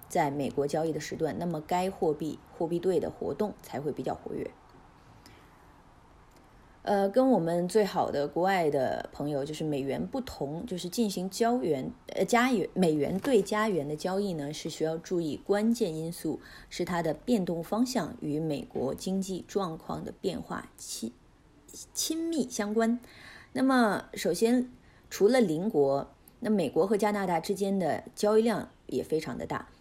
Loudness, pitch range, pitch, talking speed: -30 LUFS, 160-220 Hz, 190 Hz, 240 characters per minute